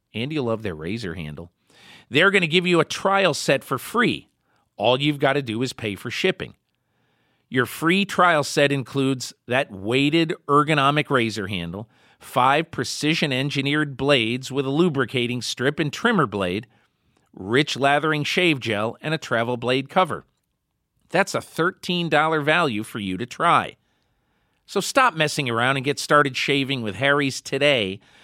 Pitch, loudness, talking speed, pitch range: 140 Hz, -21 LUFS, 155 wpm, 120-155 Hz